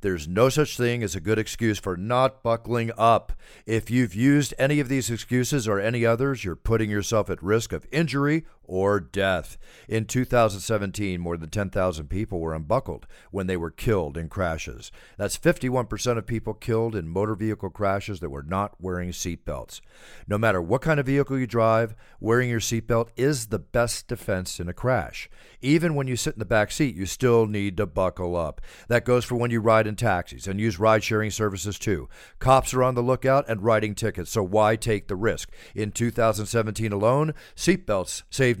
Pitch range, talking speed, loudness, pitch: 95-120 Hz, 190 wpm, -25 LUFS, 110 Hz